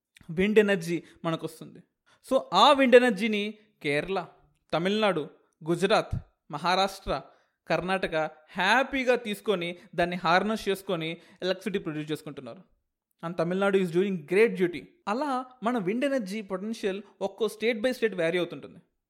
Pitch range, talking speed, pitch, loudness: 170-220 Hz, 120 wpm, 195 Hz, -27 LUFS